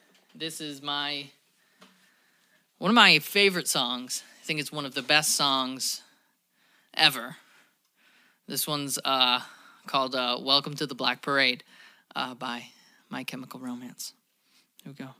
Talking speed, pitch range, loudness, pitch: 140 wpm, 130-150 Hz, -25 LUFS, 140 Hz